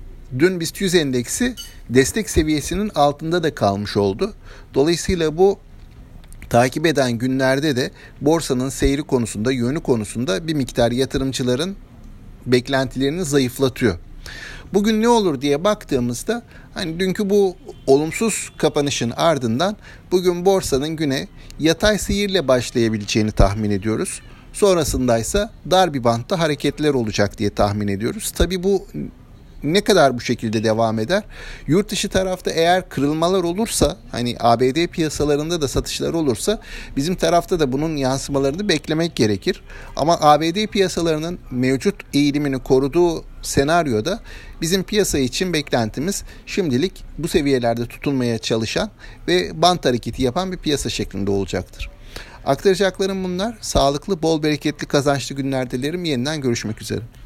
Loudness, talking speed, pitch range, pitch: -19 LUFS, 120 wpm, 120-180 Hz, 145 Hz